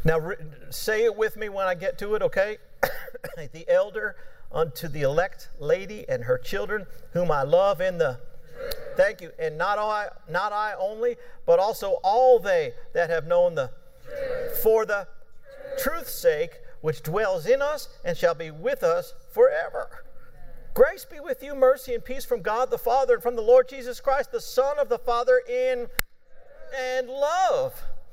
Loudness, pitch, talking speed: -25 LUFS, 270 Hz, 170 wpm